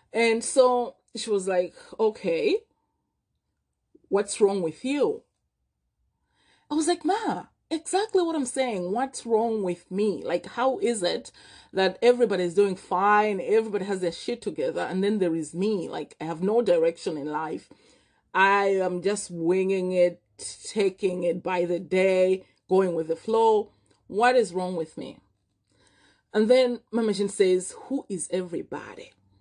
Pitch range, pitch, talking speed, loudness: 180-235 Hz, 195 Hz, 150 wpm, -25 LUFS